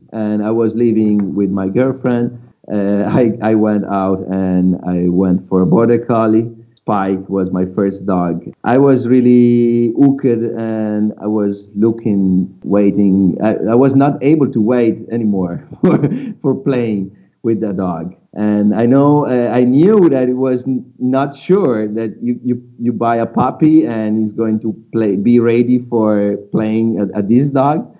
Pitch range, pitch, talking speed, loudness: 100-120 Hz, 110 Hz, 170 wpm, -14 LUFS